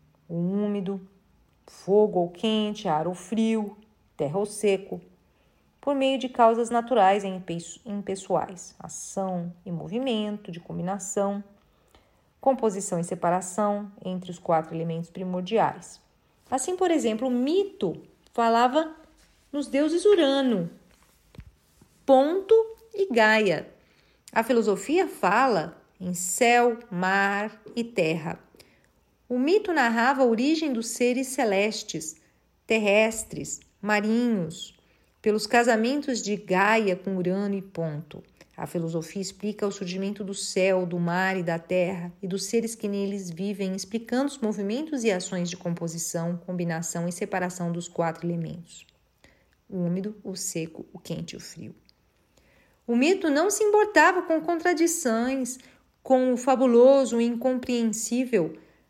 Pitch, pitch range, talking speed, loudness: 205 Hz, 180-245 Hz, 125 wpm, -25 LUFS